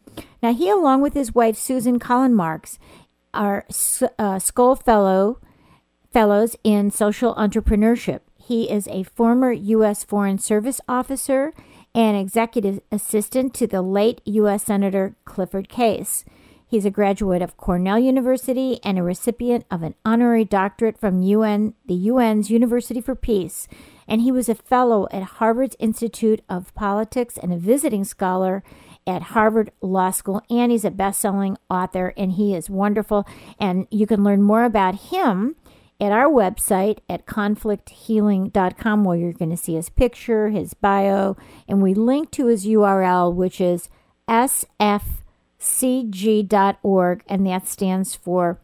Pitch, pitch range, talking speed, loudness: 210 Hz, 195-235 Hz, 145 wpm, -20 LUFS